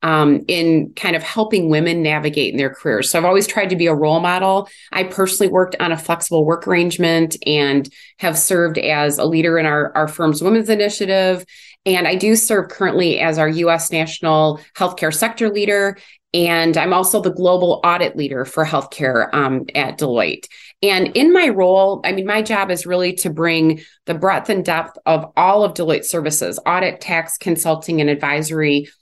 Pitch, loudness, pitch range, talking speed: 170 Hz, -16 LUFS, 155-190 Hz, 185 wpm